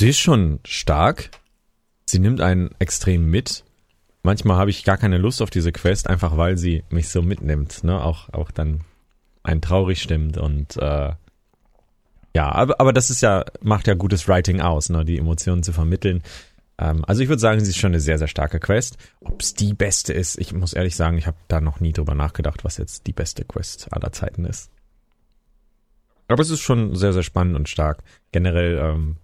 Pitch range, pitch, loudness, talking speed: 80-100 Hz, 85 Hz, -20 LUFS, 200 wpm